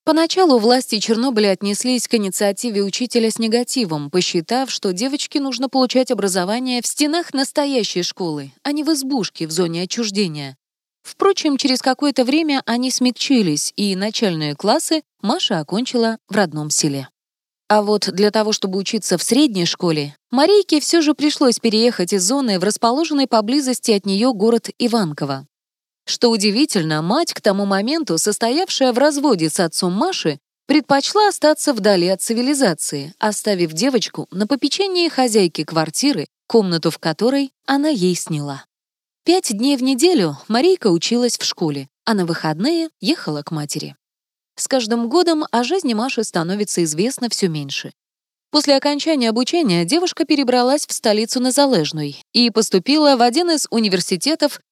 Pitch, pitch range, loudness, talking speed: 230 Hz, 190-275 Hz, -17 LUFS, 145 wpm